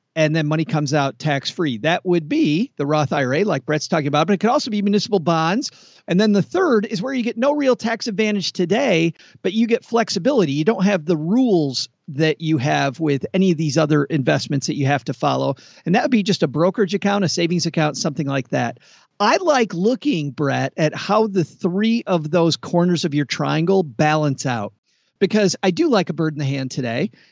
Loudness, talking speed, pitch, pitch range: -19 LUFS, 220 wpm, 165 Hz, 150-205 Hz